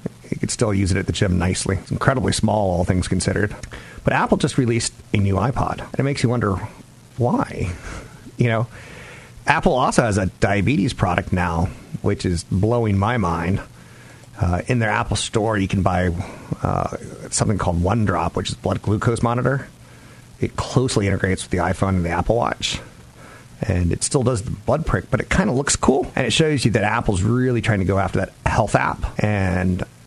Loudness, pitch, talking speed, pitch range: -20 LUFS, 105 Hz, 195 wpm, 95-120 Hz